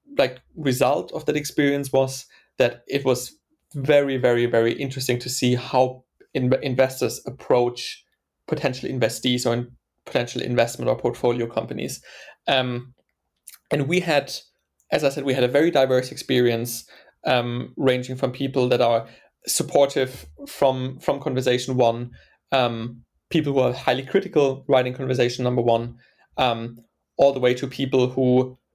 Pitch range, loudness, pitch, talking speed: 120-135 Hz, -22 LUFS, 130 Hz, 145 wpm